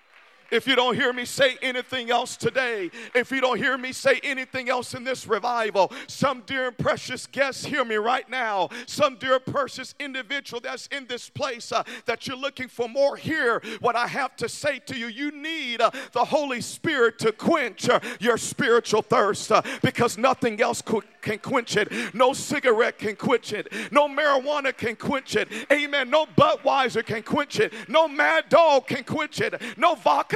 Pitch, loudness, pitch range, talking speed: 255 Hz, -24 LUFS, 235-280 Hz, 190 wpm